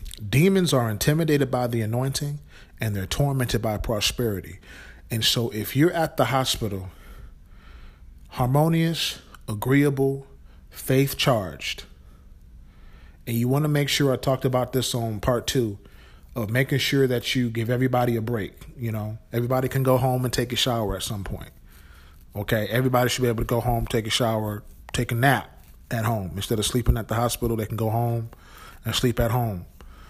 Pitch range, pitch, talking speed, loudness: 100-130 Hz, 115 Hz, 175 wpm, -24 LUFS